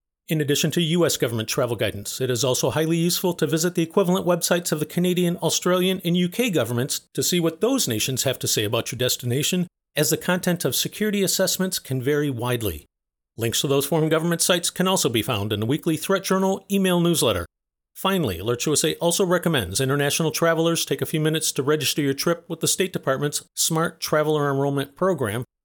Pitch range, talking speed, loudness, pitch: 135-180 Hz, 195 wpm, -22 LUFS, 160 Hz